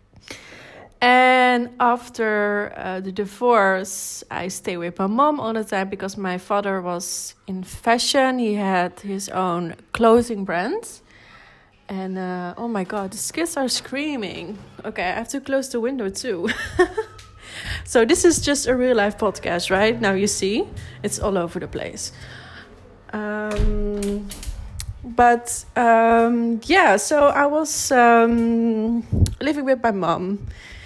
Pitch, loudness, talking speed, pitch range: 225 Hz, -20 LUFS, 140 wpm, 195-245 Hz